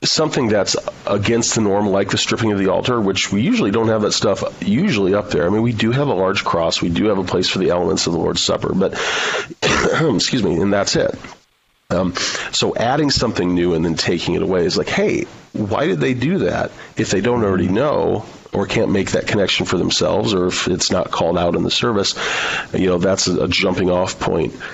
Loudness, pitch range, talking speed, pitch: -17 LUFS, 95-115 Hz, 225 wpm, 105 Hz